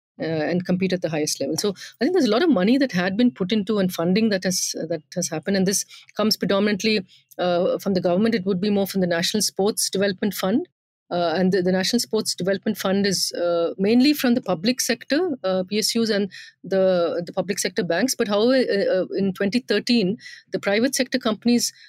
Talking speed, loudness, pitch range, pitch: 215 wpm, -22 LUFS, 185-225 Hz, 200 Hz